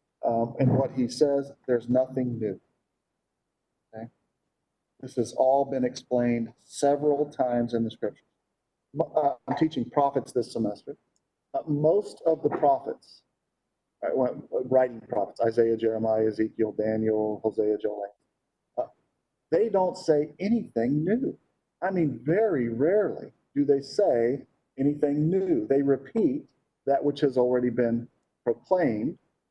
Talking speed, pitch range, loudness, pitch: 130 wpm, 115-145 Hz, -27 LUFS, 130 Hz